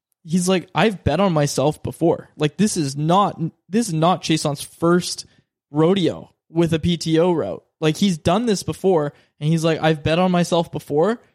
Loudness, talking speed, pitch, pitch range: -20 LUFS, 185 wpm, 165 Hz, 155-180 Hz